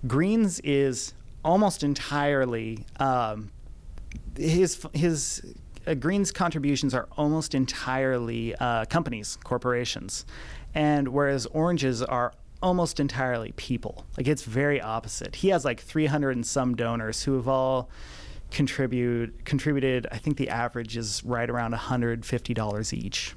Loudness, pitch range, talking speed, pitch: -27 LUFS, 115-145 Hz, 125 wpm, 130 Hz